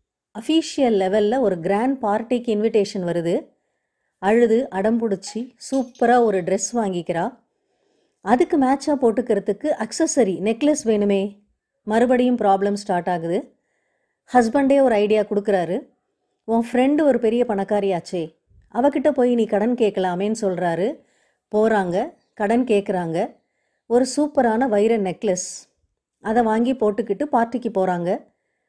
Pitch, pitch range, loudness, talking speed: 220 Hz, 195-250 Hz, -20 LUFS, 105 wpm